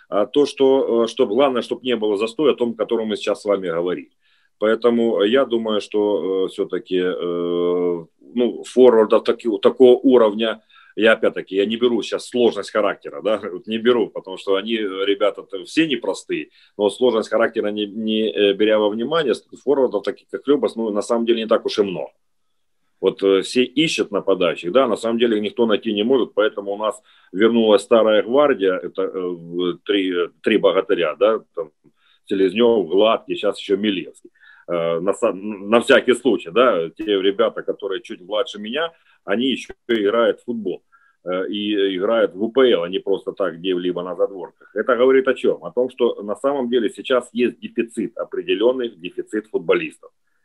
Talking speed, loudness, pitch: 165 wpm, -19 LUFS, 120 Hz